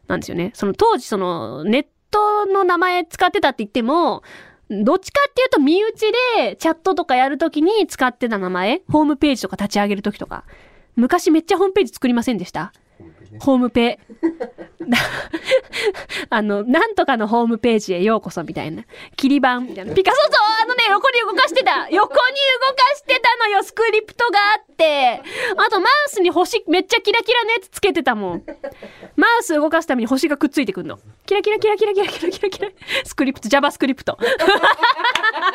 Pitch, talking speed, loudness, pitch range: 325 Hz, 390 characters per minute, -17 LUFS, 250-415 Hz